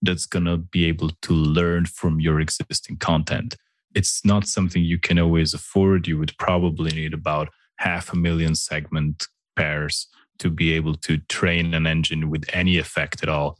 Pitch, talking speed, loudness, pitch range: 80 Hz, 175 wpm, -22 LUFS, 80-85 Hz